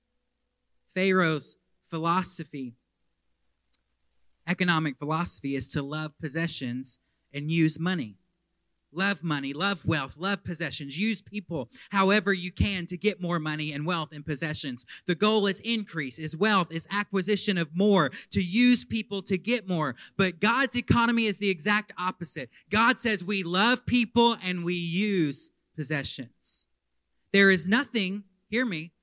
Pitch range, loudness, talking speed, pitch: 150-200 Hz, -27 LUFS, 140 wpm, 175 Hz